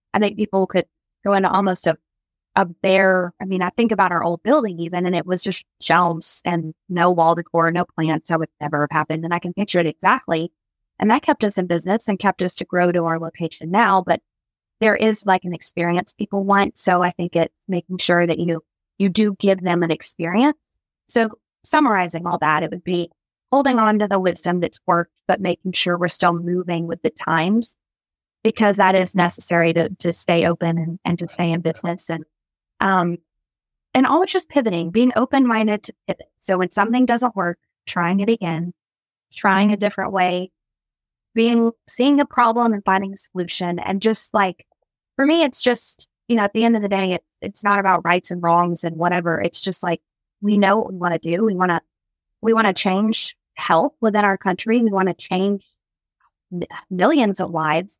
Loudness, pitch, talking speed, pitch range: -19 LUFS, 185 Hz, 205 wpm, 170-210 Hz